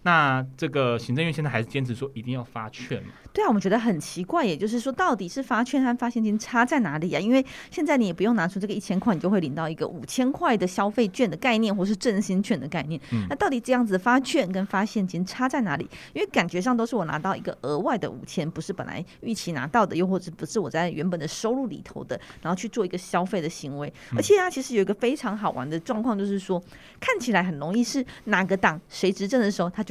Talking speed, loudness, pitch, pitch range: 385 characters per minute, -26 LUFS, 200 Hz, 170-235 Hz